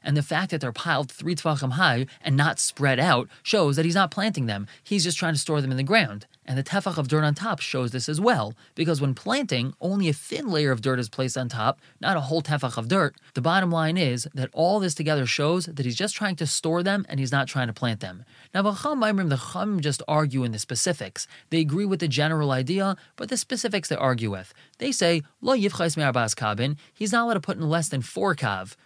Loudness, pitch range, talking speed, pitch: -25 LUFS, 130-180 Hz, 240 wpm, 155 Hz